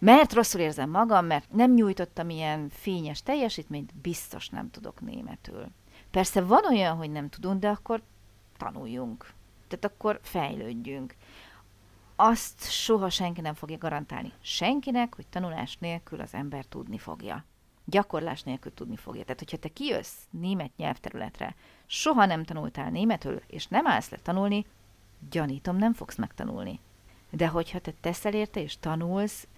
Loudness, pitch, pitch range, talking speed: -29 LUFS, 170 Hz, 145-205 Hz, 140 wpm